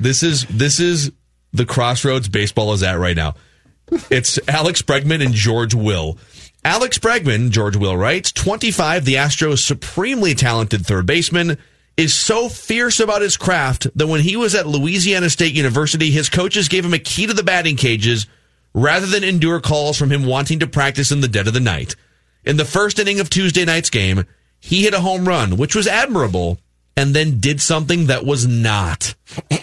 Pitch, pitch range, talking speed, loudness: 145 Hz, 115-175 Hz, 185 wpm, -16 LUFS